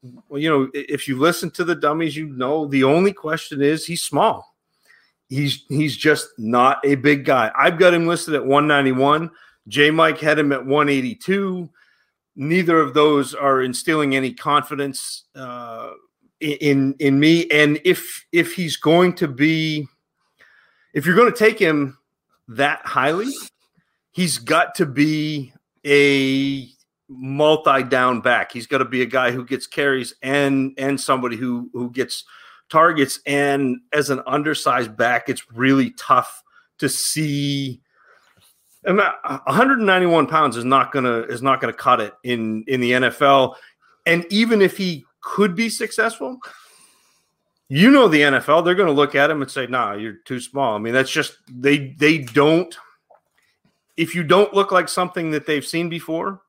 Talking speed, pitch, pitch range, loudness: 155 wpm, 145 Hz, 135-170 Hz, -18 LUFS